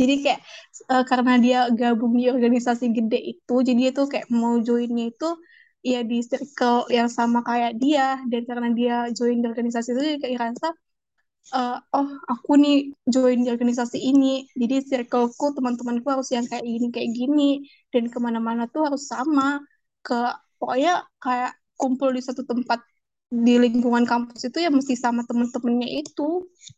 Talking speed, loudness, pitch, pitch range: 160 wpm, -23 LUFS, 250 Hz, 240-270 Hz